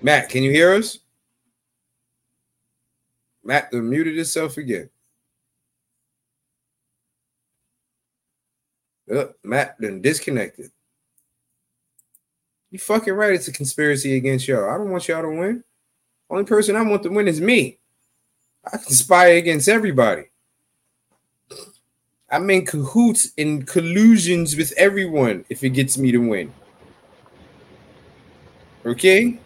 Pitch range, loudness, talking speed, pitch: 135-195 Hz, -18 LUFS, 110 wpm, 165 Hz